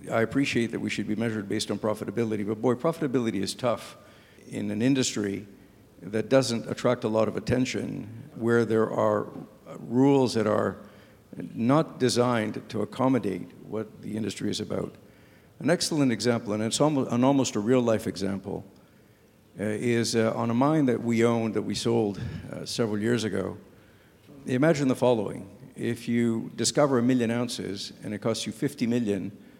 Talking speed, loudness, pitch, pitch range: 160 wpm, -27 LUFS, 115 Hz, 105-125 Hz